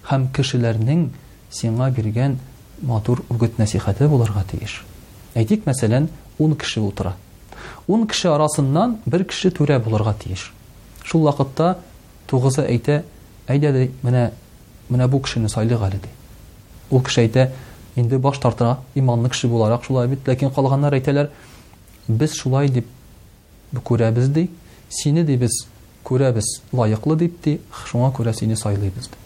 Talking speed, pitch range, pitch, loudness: 135 wpm, 110-140 Hz, 125 Hz, -20 LUFS